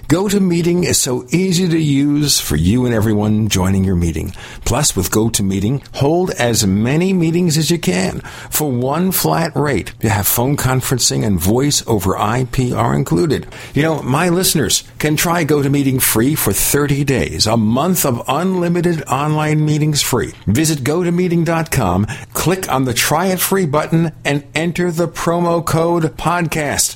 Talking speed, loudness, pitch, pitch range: 155 wpm, -15 LUFS, 145 Hz, 120-170 Hz